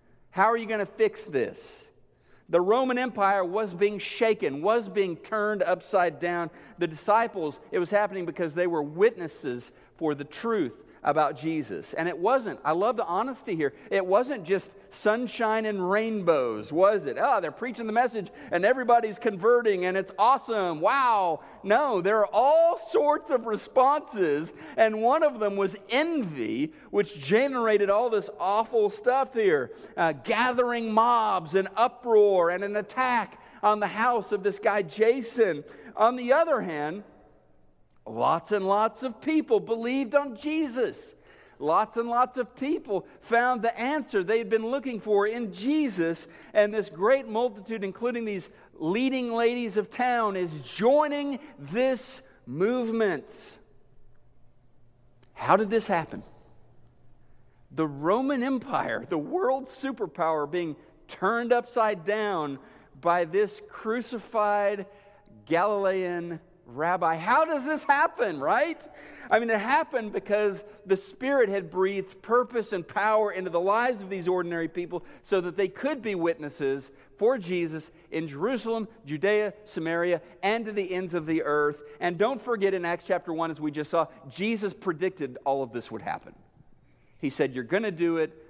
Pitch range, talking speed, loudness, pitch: 175-240 Hz, 150 wpm, -27 LUFS, 210 Hz